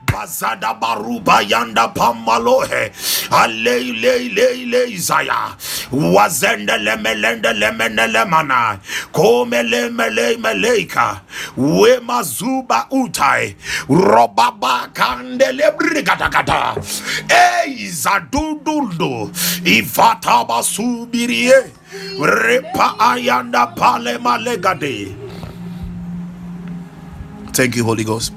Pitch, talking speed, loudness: 195 Hz, 70 wpm, -15 LUFS